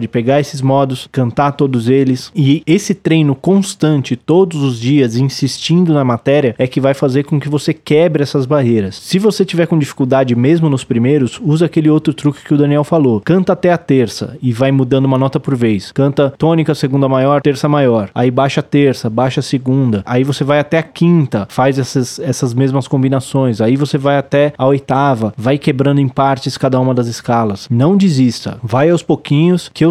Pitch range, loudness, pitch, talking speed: 130-150 Hz, -13 LUFS, 140 Hz, 200 wpm